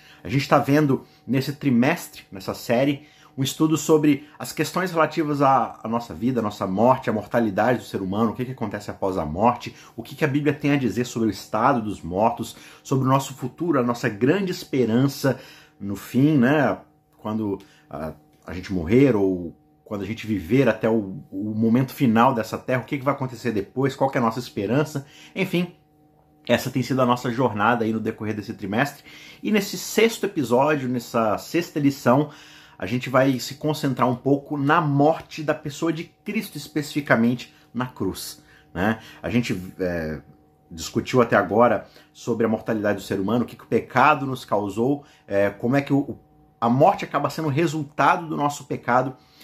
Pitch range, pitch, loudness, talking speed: 110-145 Hz, 125 Hz, -23 LUFS, 190 wpm